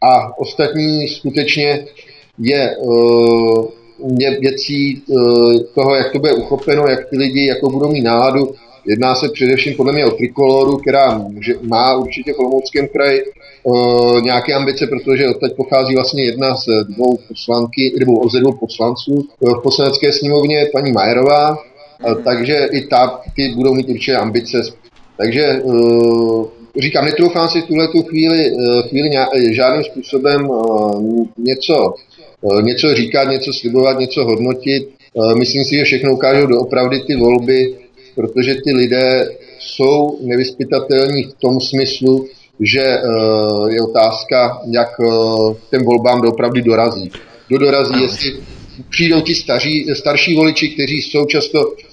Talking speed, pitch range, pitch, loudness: 125 wpm, 120-140 Hz, 130 Hz, -13 LUFS